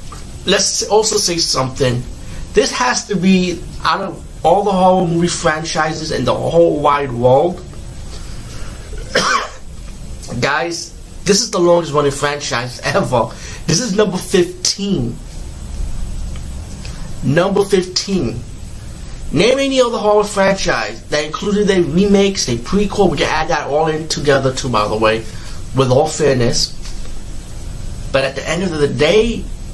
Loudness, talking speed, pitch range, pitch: -15 LUFS, 135 wpm, 125-195 Hz, 155 Hz